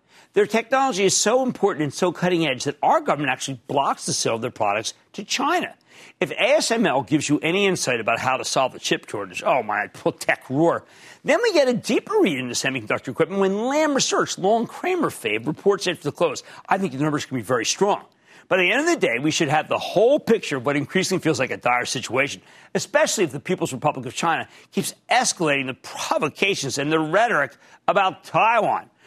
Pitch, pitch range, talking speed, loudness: 175 Hz, 140-225 Hz, 215 wpm, -22 LUFS